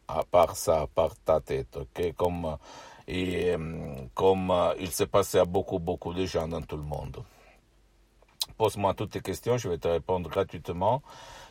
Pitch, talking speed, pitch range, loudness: 90 Hz, 140 wpm, 80-95 Hz, -29 LUFS